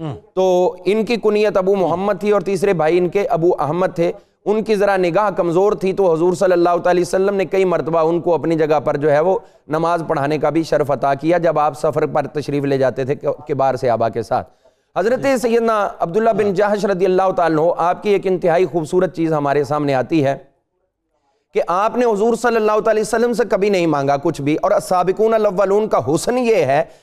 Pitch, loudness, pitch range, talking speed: 180 Hz, -17 LUFS, 155-205 Hz, 215 wpm